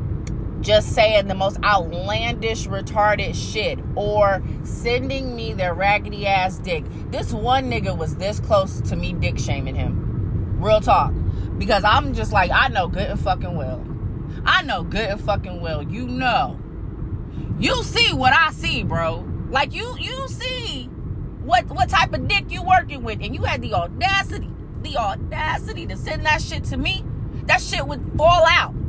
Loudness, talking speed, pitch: -21 LUFS, 170 wpm, 115 Hz